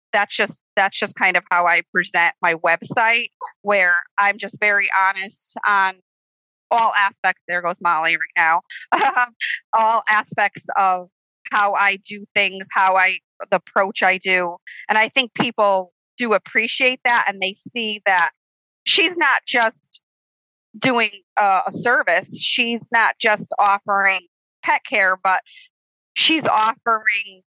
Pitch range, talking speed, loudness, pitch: 190-225 Hz, 140 wpm, -18 LUFS, 200 Hz